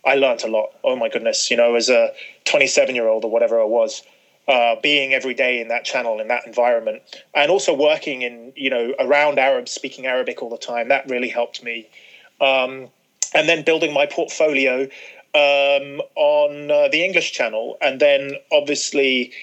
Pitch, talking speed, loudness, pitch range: 140 Hz, 185 wpm, -18 LUFS, 125-150 Hz